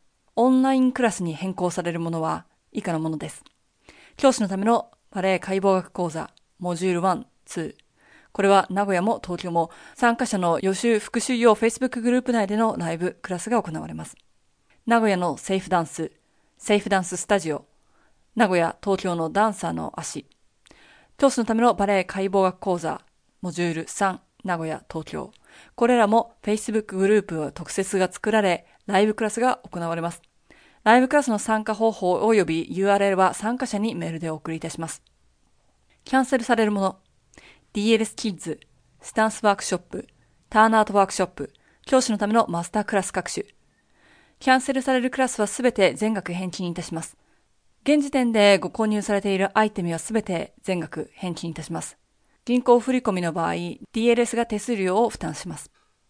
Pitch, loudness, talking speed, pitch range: 200 Hz, -23 LUFS, 365 characters per minute, 175-230 Hz